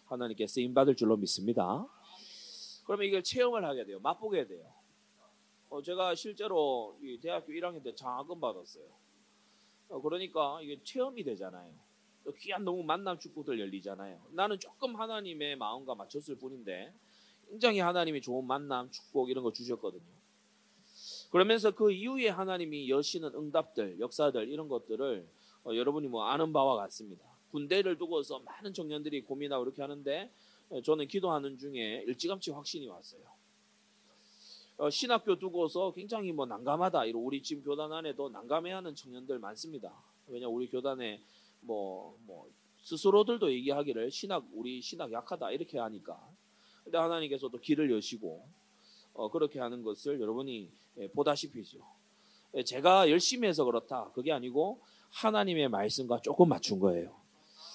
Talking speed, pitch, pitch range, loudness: 335 characters per minute, 150 Hz, 125-190 Hz, -34 LUFS